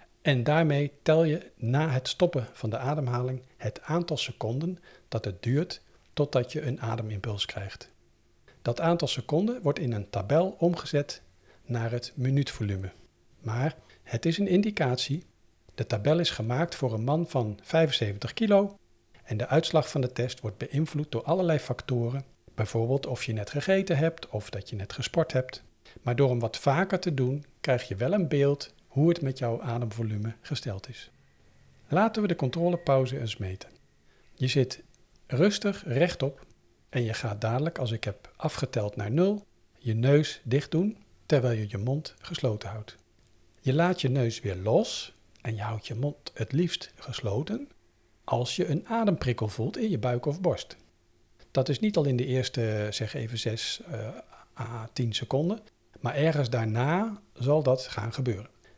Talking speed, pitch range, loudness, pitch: 165 wpm, 115-155 Hz, -29 LUFS, 130 Hz